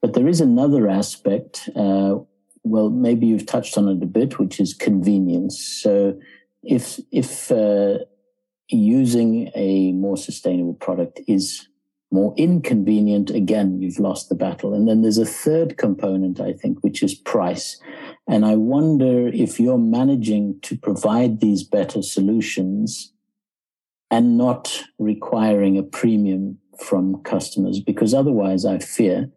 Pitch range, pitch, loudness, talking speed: 95-125 Hz, 105 Hz, -19 LUFS, 135 wpm